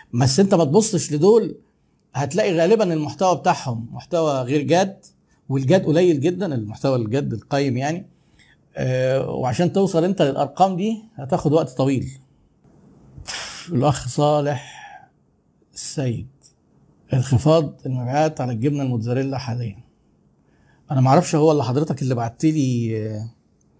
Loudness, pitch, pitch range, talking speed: -20 LUFS, 145 Hz, 125-165 Hz, 110 wpm